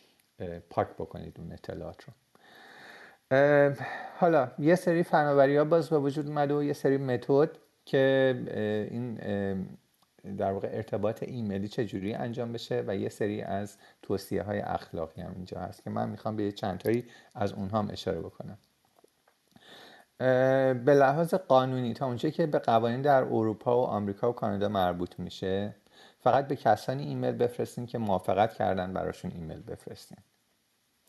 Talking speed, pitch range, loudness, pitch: 150 wpm, 100-140 Hz, -29 LUFS, 120 Hz